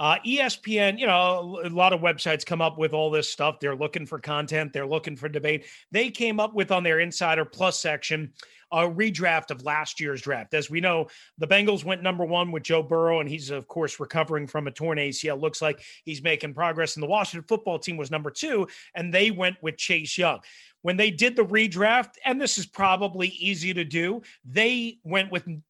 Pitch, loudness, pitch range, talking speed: 170 Hz, -25 LUFS, 155-190 Hz, 215 wpm